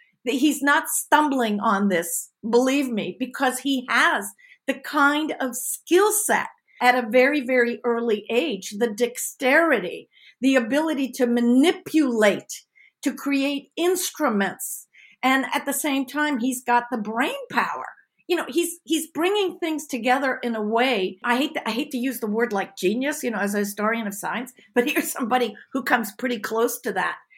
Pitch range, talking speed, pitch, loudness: 235-290 Hz, 170 wpm, 255 Hz, -23 LUFS